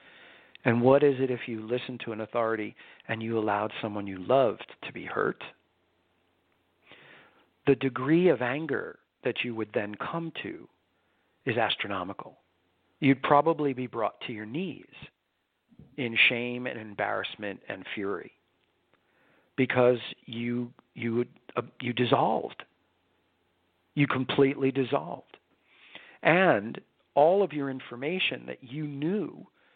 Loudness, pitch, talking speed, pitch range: -28 LUFS, 120 Hz, 125 wpm, 105-135 Hz